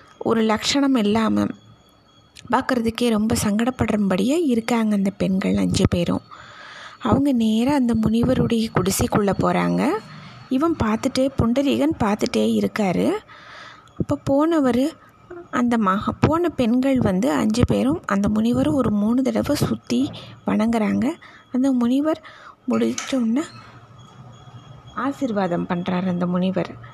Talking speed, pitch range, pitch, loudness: 100 wpm, 180-260 Hz, 225 Hz, -21 LUFS